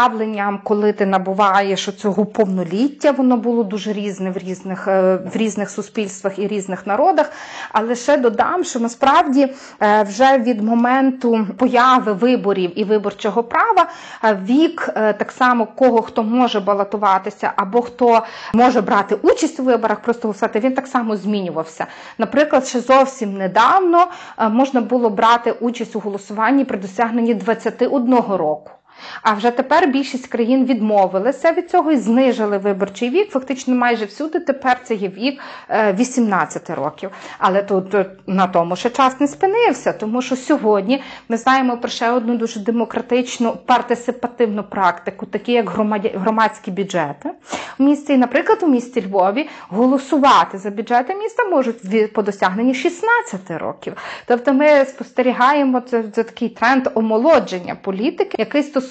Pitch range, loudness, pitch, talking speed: 210-265 Hz, -17 LUFS, 235 Hz, 135 wpm